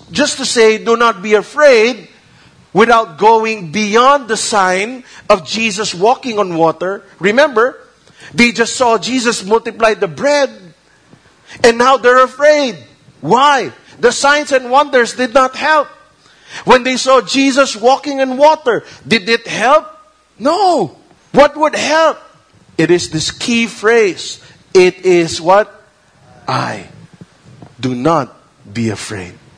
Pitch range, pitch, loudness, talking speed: 200-275 Hz, 230 Hz, -12 LUFS, 130 wpm